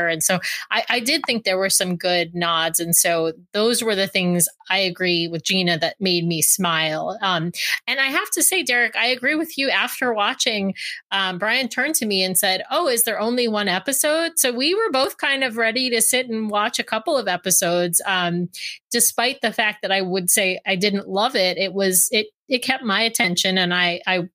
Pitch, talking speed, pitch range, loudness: 195 Hz, 215 wpm, 180-240 Hz, -19 LUFS